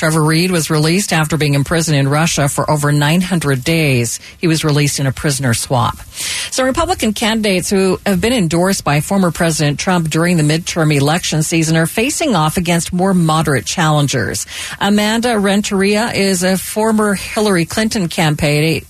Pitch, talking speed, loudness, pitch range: 165 Hz, 160 wpm, -14 LUFS, 150-195 Hz